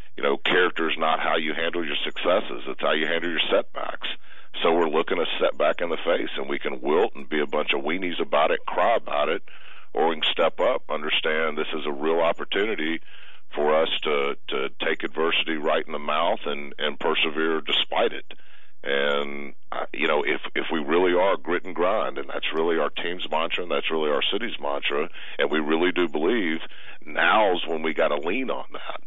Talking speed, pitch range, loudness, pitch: 210 wpm, 75-85 Hz, -24 LUFS, 80 Hz